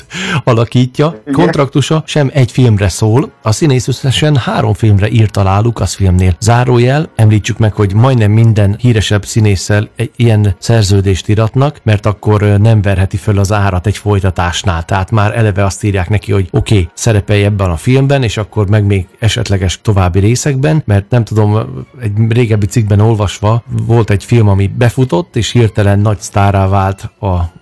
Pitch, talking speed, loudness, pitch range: 110 Hz, 160 wpm, -11 LUFS, 100-120 Hz